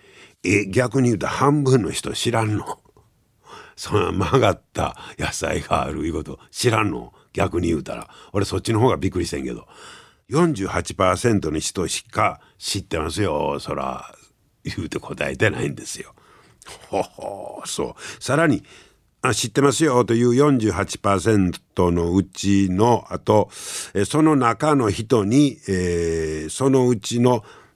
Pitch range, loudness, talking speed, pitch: 95-130 Hz, -21 LUFS, 255 characters per minute, 110 Hz